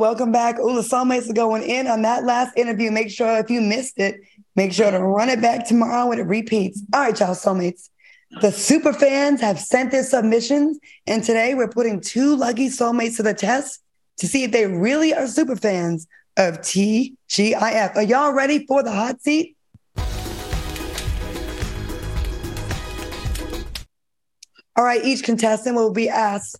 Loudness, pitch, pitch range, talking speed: -20 LUFS, 230 Hz, 205-255 Hz, 170 wpm